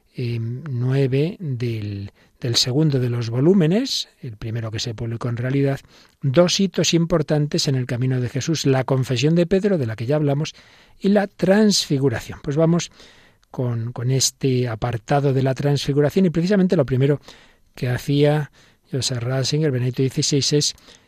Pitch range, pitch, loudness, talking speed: 125-155 Hz, 135 Hz, -20 LUFS, 155 wpm